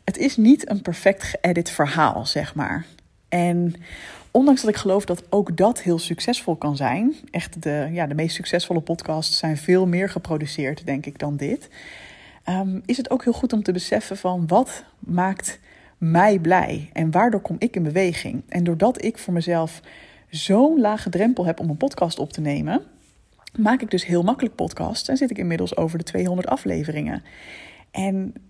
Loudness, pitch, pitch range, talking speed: -22 LUFS, 180 Hz, 165-210 Hz, 180 wpm